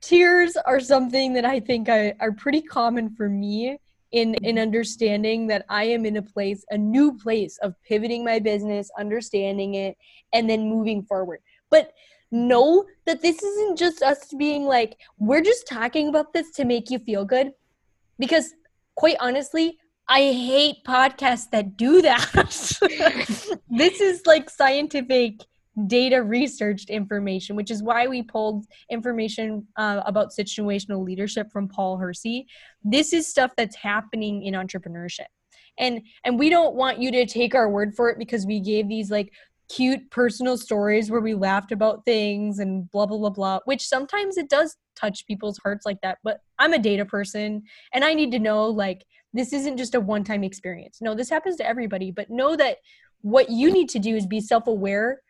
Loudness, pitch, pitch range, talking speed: -22 LUFS, 230 Hz, 210-275 Hz, 175 wpm